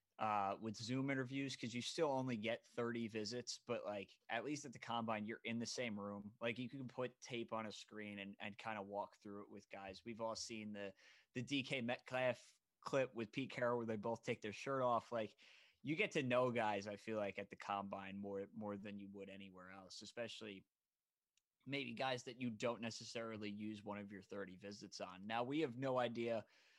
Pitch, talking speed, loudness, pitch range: 115 Hz, 215 wpm, -45 LUFS, 100-125 Hz